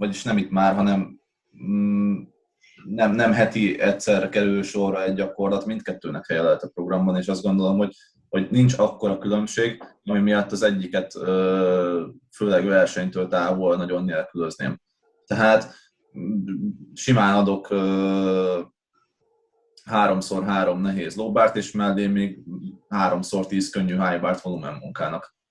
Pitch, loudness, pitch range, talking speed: 95 Hz, -22 LUFS, 95-100 Hz, 125 wpm